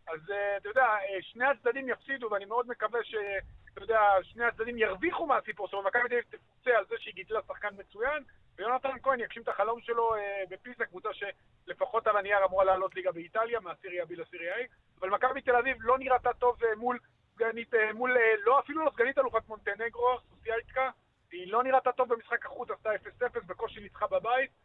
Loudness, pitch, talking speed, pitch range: -31 LUFS, 230 Hz, 185 wpm, 205-250 Hz